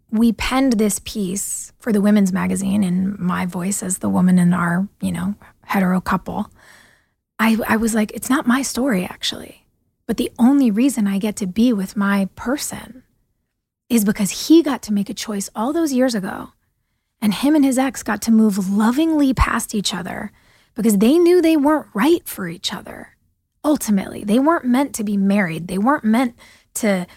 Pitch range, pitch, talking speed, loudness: 195-255 Hz, 215 Hz, 185 wpm, -18 LUFS